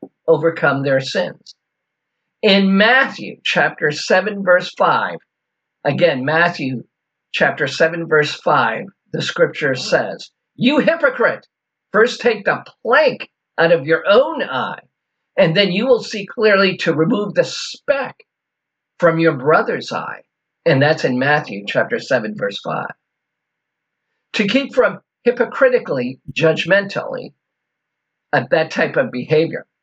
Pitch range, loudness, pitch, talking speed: 160-240 Hz, -17 LUFS, 185 Hz, 125 wpm